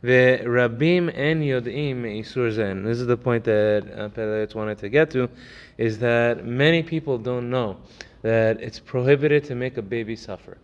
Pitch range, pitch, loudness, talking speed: 110-130 Hz, 120 Hz, -22 LUFS, 160 wpm